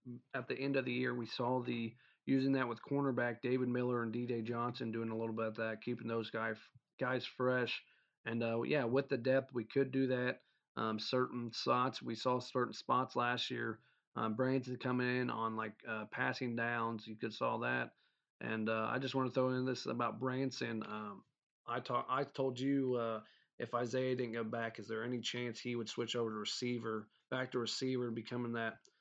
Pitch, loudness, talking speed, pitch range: 120 Hz, -39 LUFS, 205 wpm, 115-130 Hz